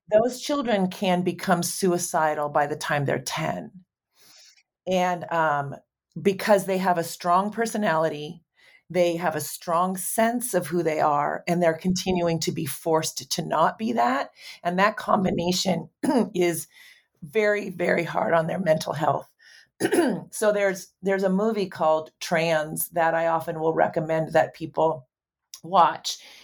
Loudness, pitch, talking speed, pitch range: -24 LUFS, 175 Hz, 145 wpm, 160-195 Hz